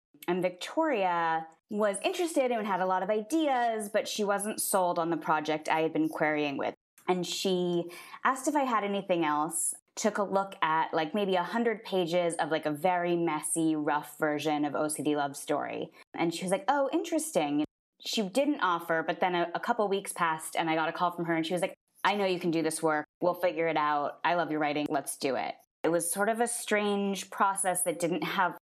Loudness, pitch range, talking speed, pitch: -30 LUFS, 160-210 Hz, 220 wpm, 180 Hz